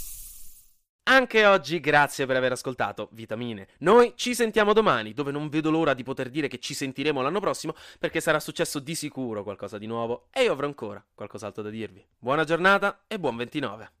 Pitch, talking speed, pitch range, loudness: 145 Hz, 185 wpm, 115-165 Hz, -25 LUFS